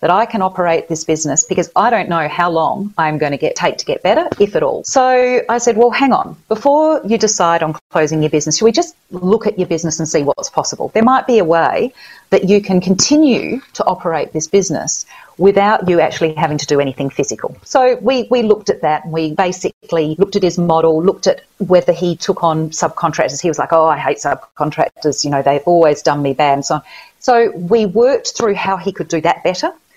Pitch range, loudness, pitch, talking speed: 160-230 Hz, -14 LUFS, 180 Hz, 230 wpm